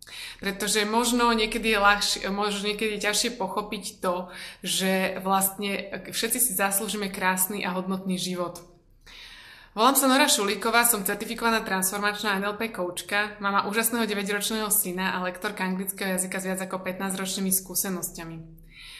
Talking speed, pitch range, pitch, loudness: 135 wpm, 190-215 Hz, 200 Hz, -25 LUFS